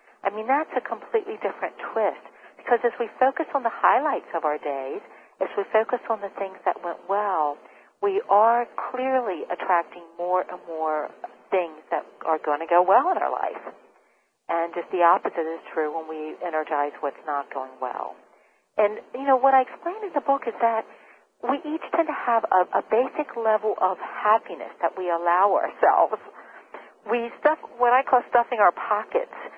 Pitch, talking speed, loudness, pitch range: 210 Hz, 185 wpm, -24 LUFS, 170-255 Hz